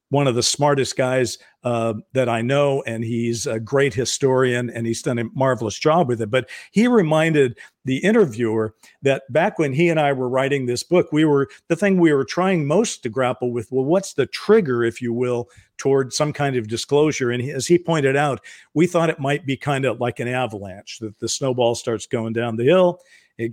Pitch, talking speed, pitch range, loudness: 130 Hz, 210 wpm, 120-150 Hz, -20 LUFS